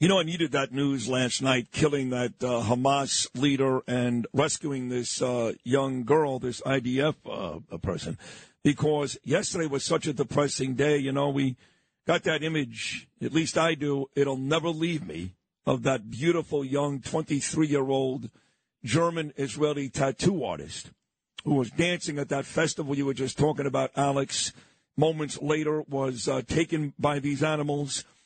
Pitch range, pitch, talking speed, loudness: 130-155 Hz, 140 Hz, 155 wpm, -27 LUFS